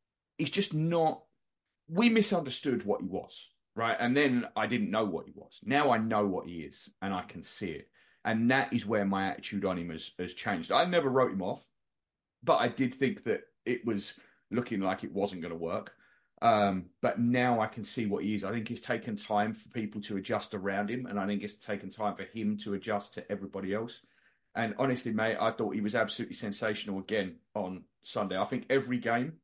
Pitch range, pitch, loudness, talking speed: 100-125 Hz, 110 Hz, -32 LUFS, 220 wpm